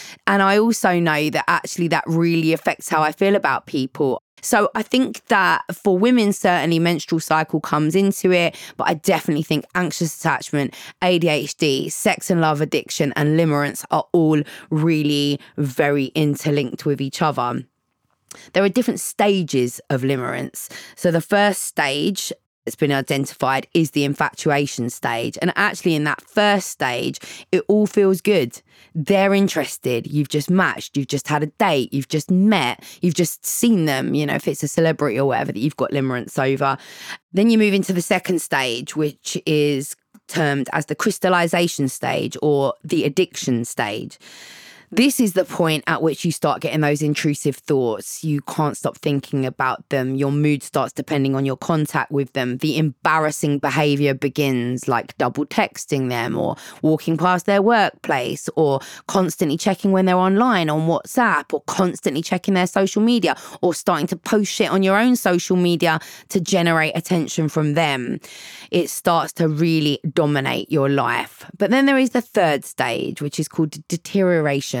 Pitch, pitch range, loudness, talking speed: 160 Hz, 145-185 Hz, -20 LUFS, 170 wpm